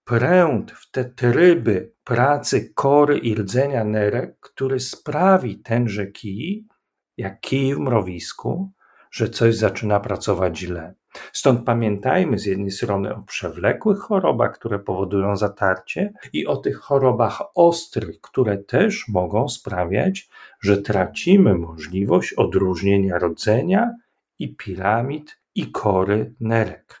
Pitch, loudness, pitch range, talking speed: 115 Hz, -20 LUFS, 100-140 Hz, 115 wpm